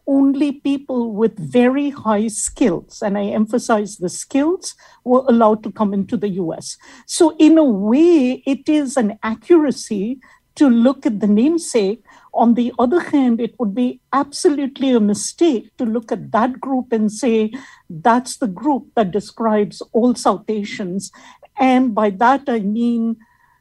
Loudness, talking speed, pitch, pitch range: -17 LUFS, 155 wpm, 240 Hz, 215-275 Hz